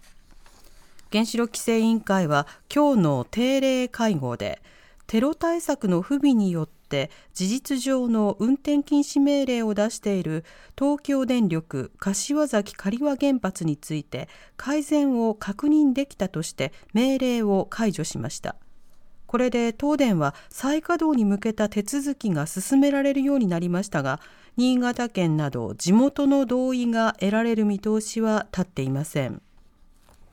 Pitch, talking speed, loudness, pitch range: 225 Hz, 270 characters per minute, -24 LUFS, 185-270 Hz